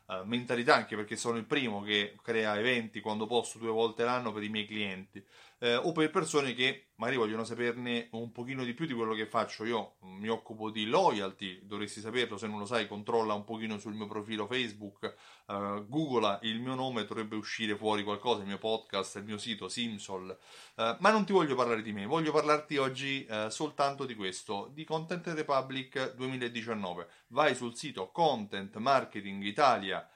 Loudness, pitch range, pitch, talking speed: -33 LUFS, 105-130 Hz, 115 Hz, 185 wpm